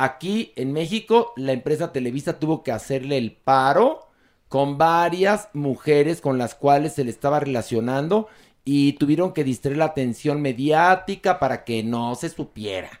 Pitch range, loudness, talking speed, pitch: 130-165 Hz, -22 LUFS, 150 wpm, 140 Hz